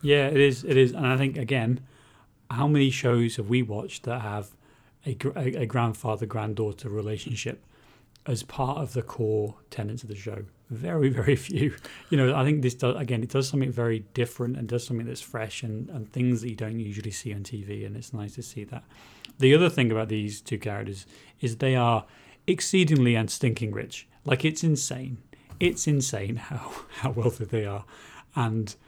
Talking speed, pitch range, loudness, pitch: 190 wpm, 110-135 Hz, -27 LUFS, 120 Hz